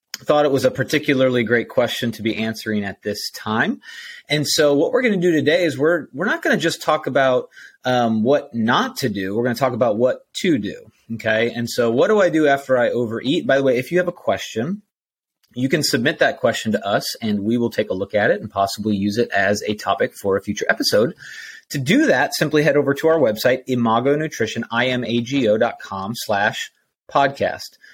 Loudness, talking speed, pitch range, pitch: -19 LUFS, 215 wpm, 110-145 Hz, 125 Hz